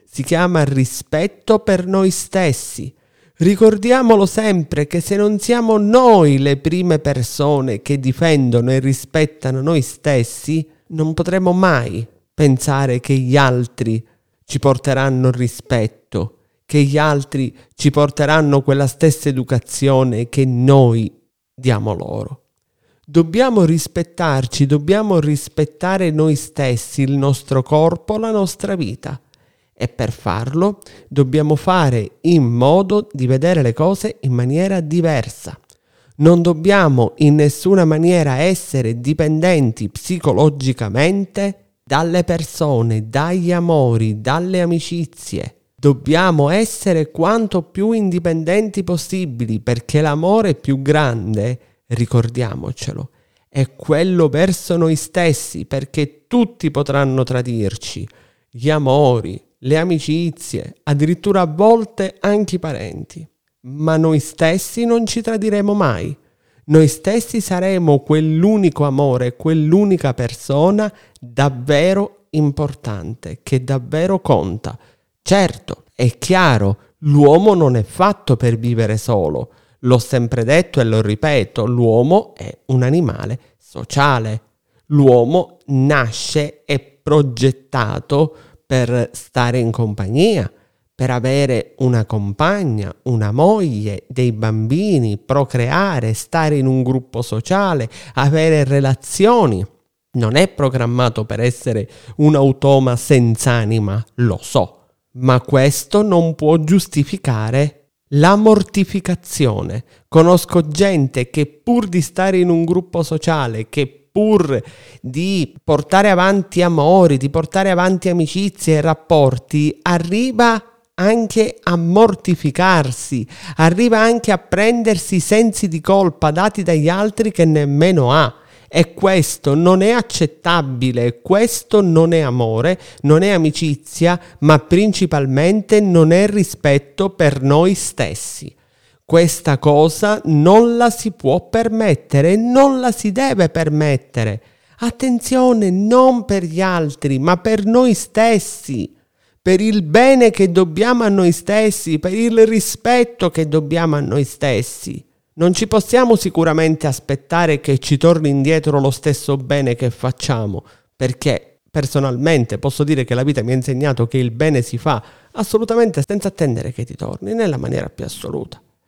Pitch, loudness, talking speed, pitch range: 150 Hz, -15 LUFS, 120 wpm, 130-185 Hz